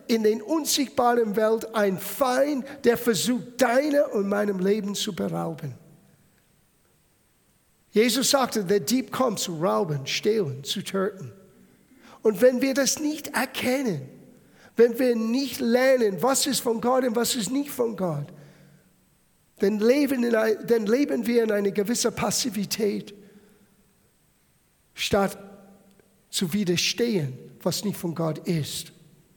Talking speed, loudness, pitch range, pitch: 130 wpm, -24 LUFS, 195-250 Hz, 215 Hz